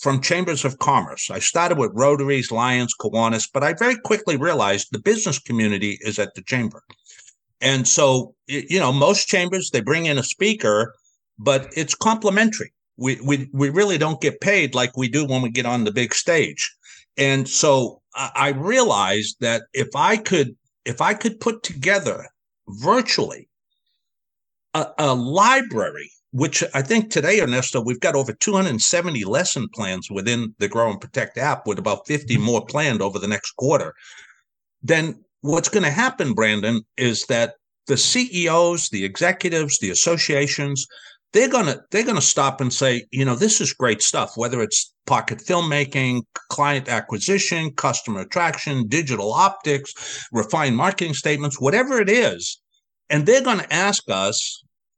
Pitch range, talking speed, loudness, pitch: 120-175 Hz, 155 wpm, -20 LUFS, 140 Hz